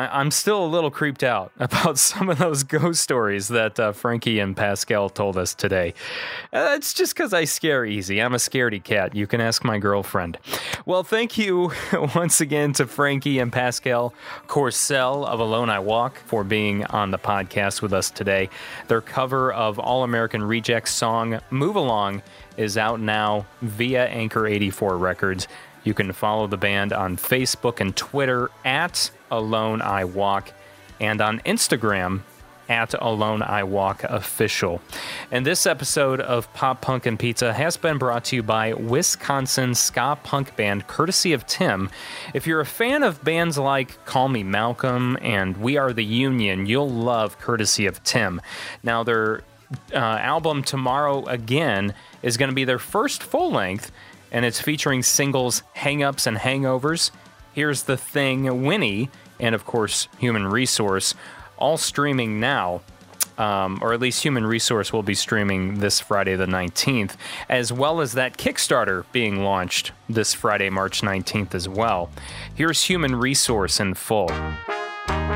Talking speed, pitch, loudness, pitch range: 160 wpm, 115 Hz, -22 LUFS, 100-135 Hz